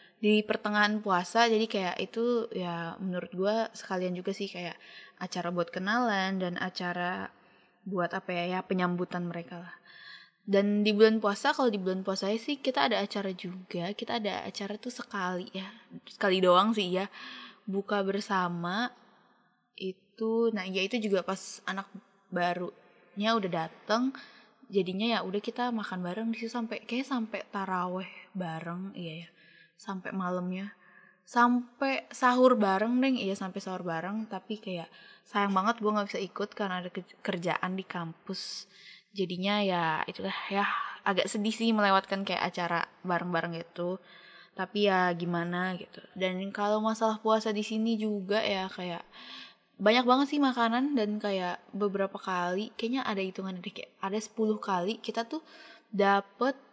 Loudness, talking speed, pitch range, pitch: -31 LUFS, 150 wpm, 185-220 Hz, 200 Hz